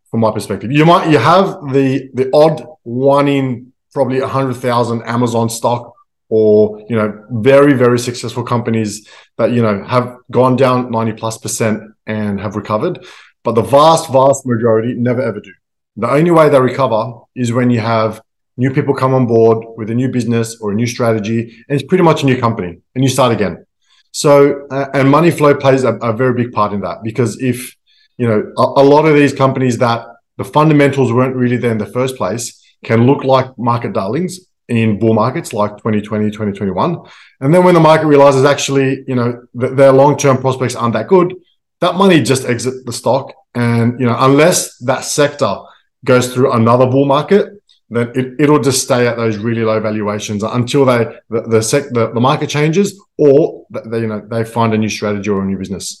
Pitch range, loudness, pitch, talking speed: 115-140 Hz, -13 LUFS, 125 Hz, 200 wpm